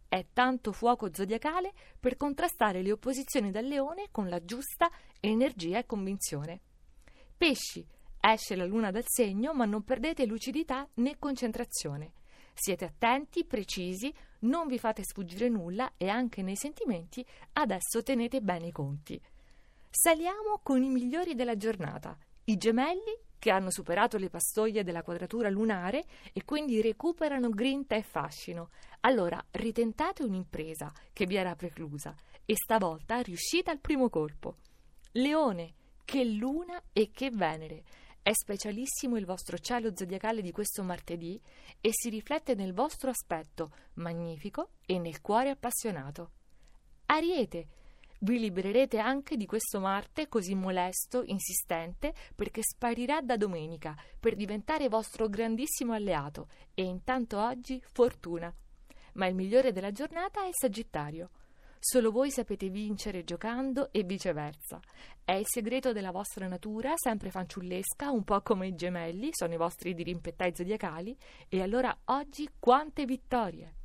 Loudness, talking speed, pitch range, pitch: -32 LUFS, 135 wpm, 185-260 Hz, 220 Hz